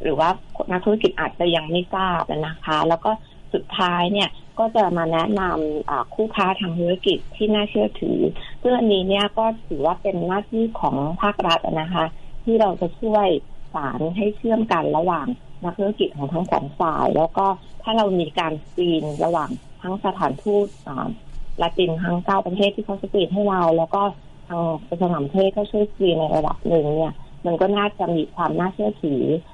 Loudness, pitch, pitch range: -22 LUFS, 185 Hz, 165-205 Hz